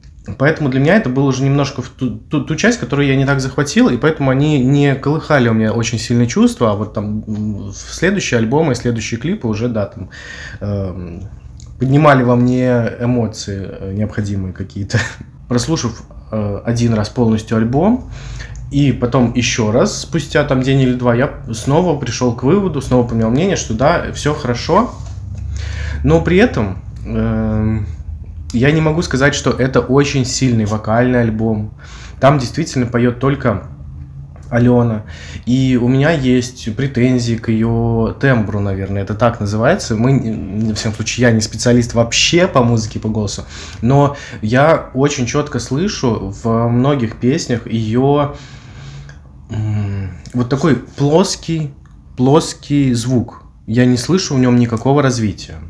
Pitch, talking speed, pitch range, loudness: 120 Hz, 150 wpm, 110-135 Hz, -15 LUFS